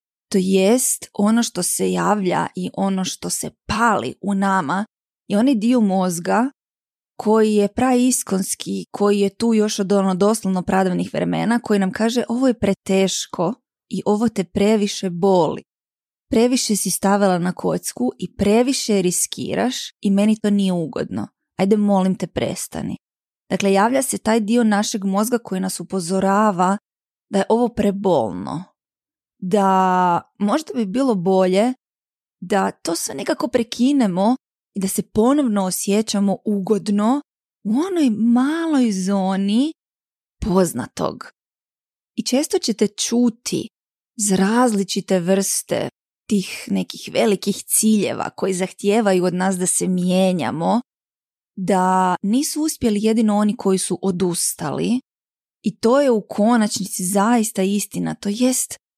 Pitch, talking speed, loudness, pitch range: 205 Hz, 130 wpm, -19 LUFS, 190-230 Hz